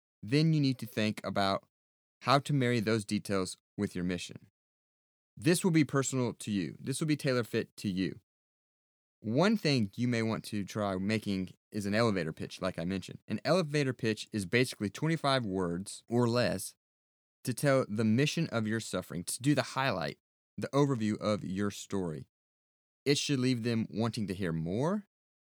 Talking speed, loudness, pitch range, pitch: 175 wpm, -32 LUFS, 95-130 Hz, 110 Hz